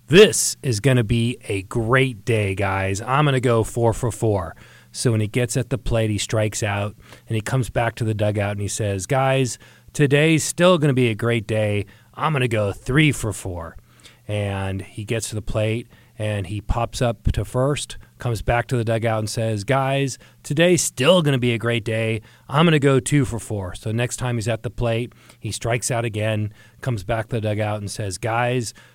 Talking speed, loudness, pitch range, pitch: 220 wpm, -21 LUFS, 105-125 Hz, 115 Hz